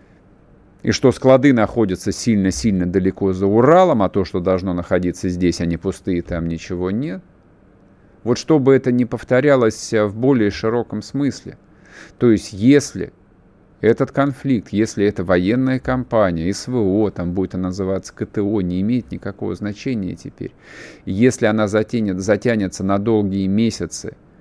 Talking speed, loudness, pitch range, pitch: 140 wpm, -18 LUFS, 95-120 Hz, 105 Hz